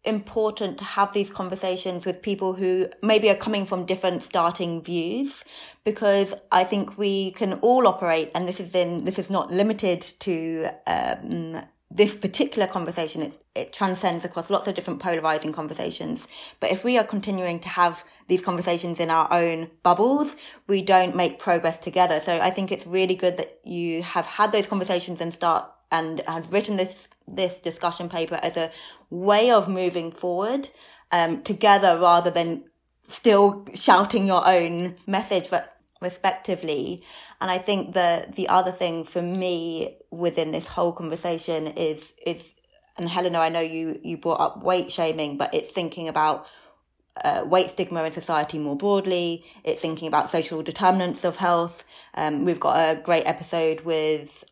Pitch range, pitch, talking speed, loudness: 165-195 Hz, 180 Hz, 165 wpm, -24 LUFS